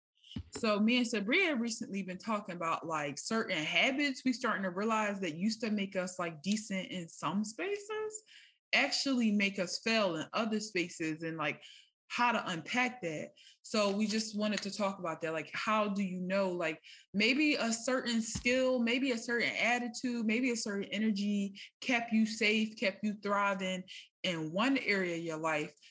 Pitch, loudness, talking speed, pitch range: 210 Hz, -33 LUFS, 175 wpm, 185-235 Hz